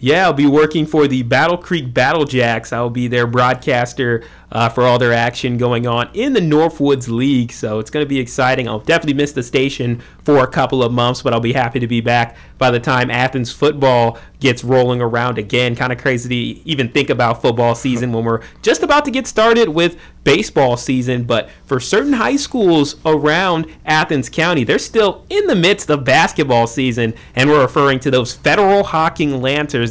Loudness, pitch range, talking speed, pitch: -15 LUFS, 120-150 Hz, 200 wpm, 130 Hz